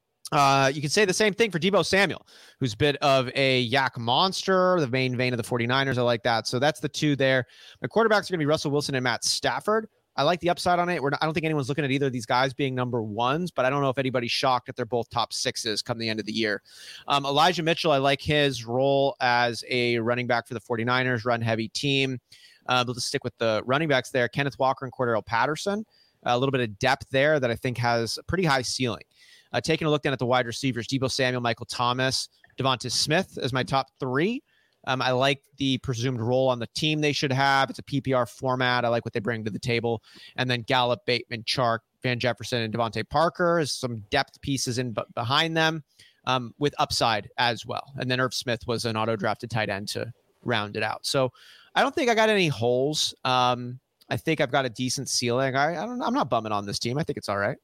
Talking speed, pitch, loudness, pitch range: 245 wpm, 130 Hz, -25 LUFS, 120-145 Hz